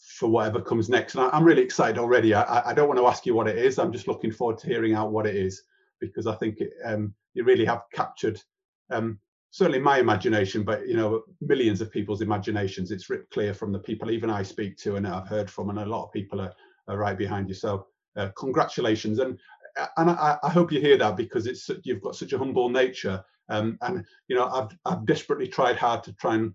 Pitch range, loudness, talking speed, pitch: 105-130 Hz, -26 LUFS, 235 wpm, 110 Hz